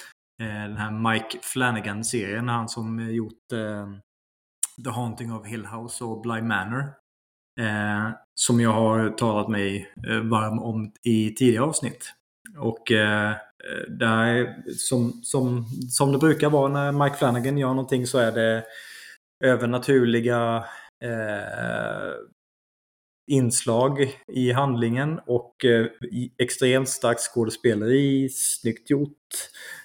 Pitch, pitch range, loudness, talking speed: 115 Hz, 110-130 Hz, -24 LUFS, 115 wpm